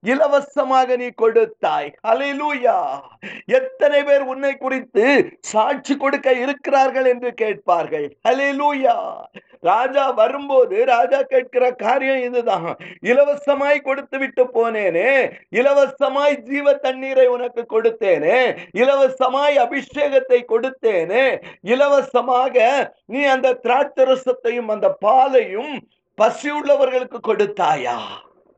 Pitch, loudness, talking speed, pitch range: 270 Hz, -18 LUFS, 85 wpm, 250-285 Hz